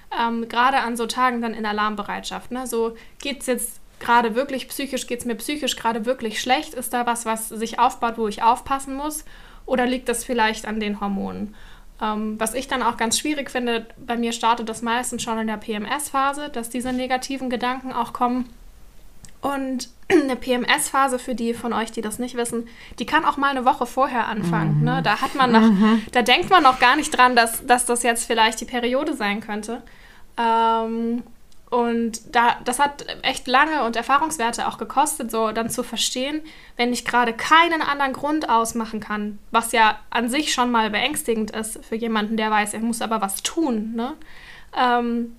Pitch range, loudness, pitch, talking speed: 225-255 Hz, -21 LUFS, 235 Hz, 185 wpm